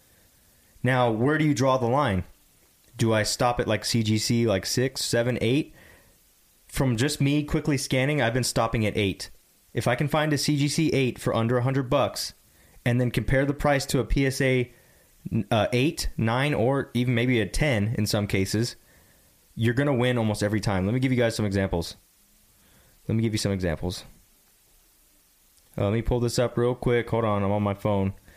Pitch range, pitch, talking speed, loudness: 105-130 Hz, 120 Hz, 190 wpm, -25 LUFS